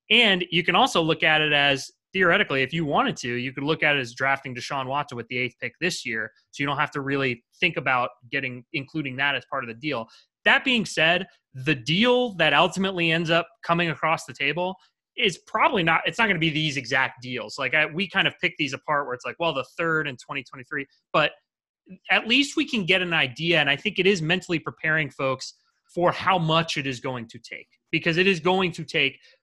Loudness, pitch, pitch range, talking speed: -23 LUFS, 155 Hz, 135-175 Hz, 230 wpm